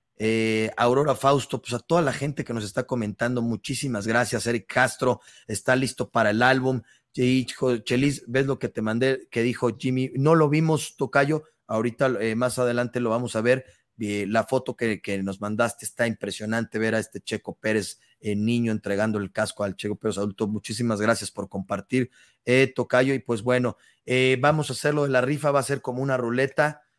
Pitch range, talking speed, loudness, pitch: 110-130 Hz, 190 wpm, -25 LUFS, 120 Hz